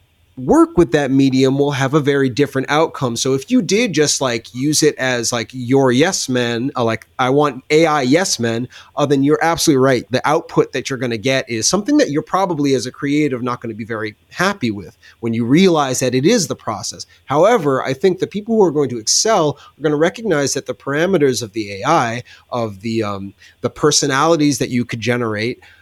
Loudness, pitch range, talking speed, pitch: -16 LUFS, 120-150 Hz, 215 wpm, 135 Hz